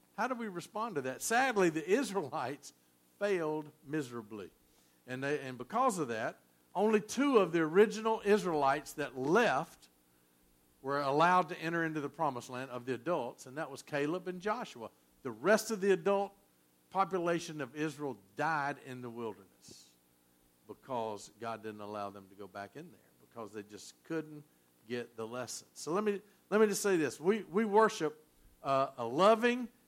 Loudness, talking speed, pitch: -34 LUFS, 170 wpm, 145 Hz